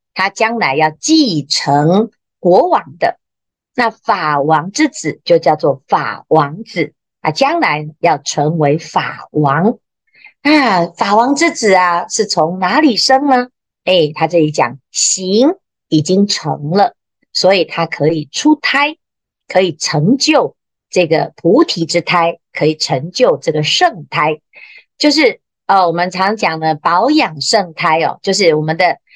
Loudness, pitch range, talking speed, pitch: -13 LUFS, 155-245 Hz, 195 characters per minute, 180 Hz